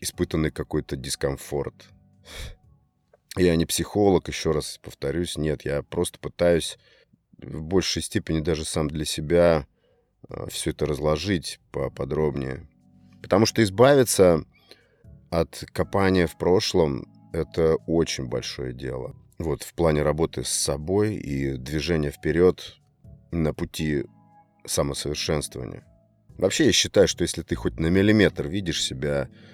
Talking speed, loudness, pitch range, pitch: 120 wpm, -24 LUFS, 75-90 Hz, 80 Hz